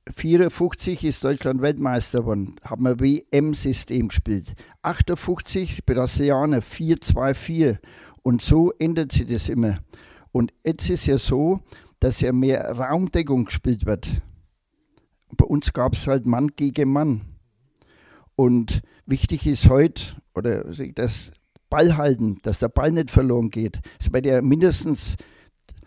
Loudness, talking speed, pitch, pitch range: -22 LUFS, 135 wpm, 130 Hz, 110-150 Hz